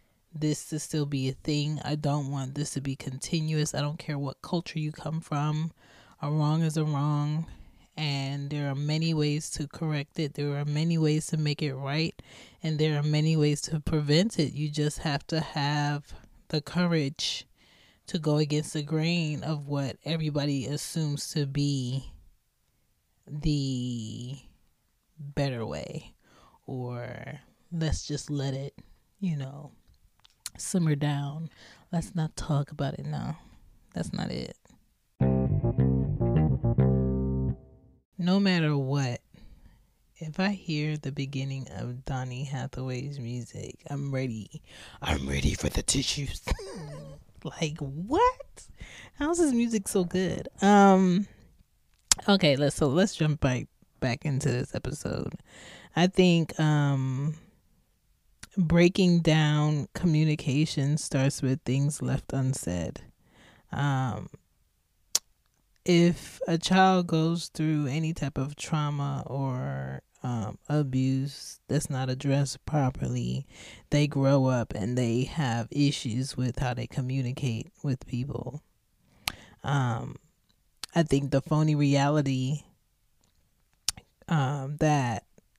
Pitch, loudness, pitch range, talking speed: 145 Hz, -28 LUFS, 130-155 Hz, 125 wpm